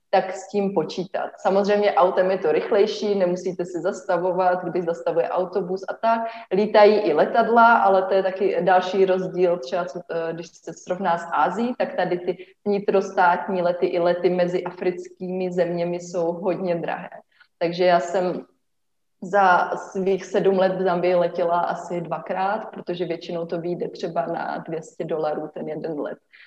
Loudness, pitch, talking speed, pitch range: -22 LUFS, 185 Hz, 155 wpm, 175-195 Hz